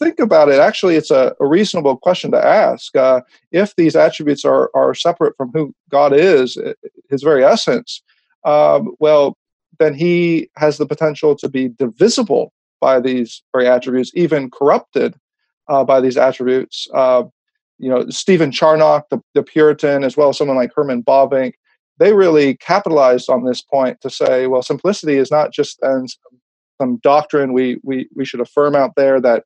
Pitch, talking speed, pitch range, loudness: 145 Hz, 170 wpm, 130-160 Hz, -14 LUFS